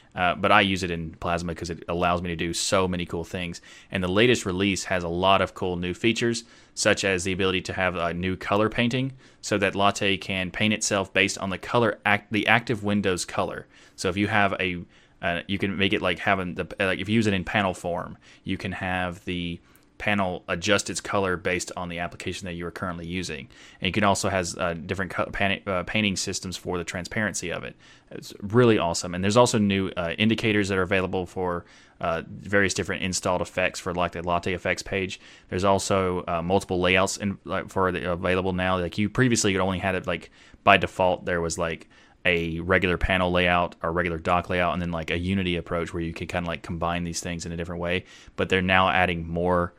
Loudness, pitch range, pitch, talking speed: -25 LUFS, 85-100 Hz, 95 Hz, 230 wpm